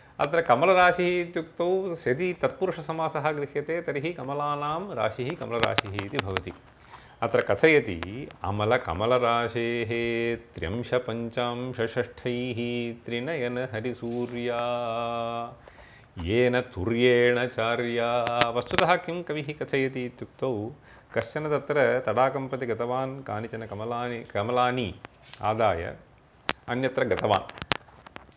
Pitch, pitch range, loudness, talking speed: 125 Hz, 115-140 Hz, -27 LUFS, 55 wpm